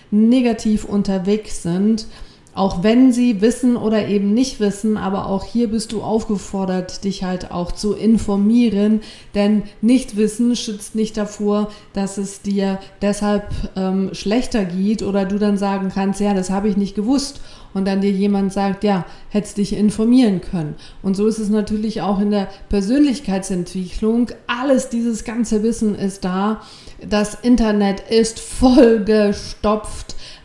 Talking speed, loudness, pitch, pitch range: 150 wpm, -18 LUFS, 210 Hz, 195-220 Hz